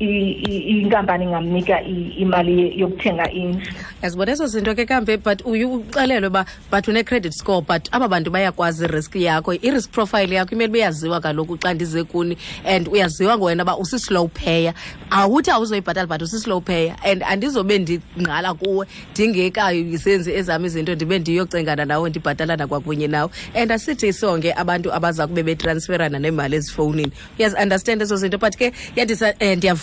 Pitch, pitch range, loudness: 185 Hz, 170-210 Hz, -19 LUFS